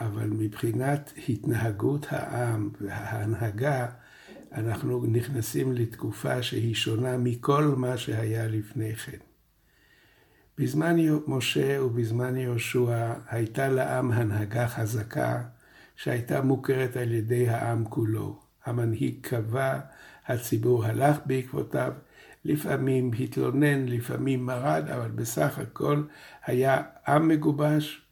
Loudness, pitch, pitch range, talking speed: -28 LUFS, 125 Hz, 115-135 Hz, 95 wpm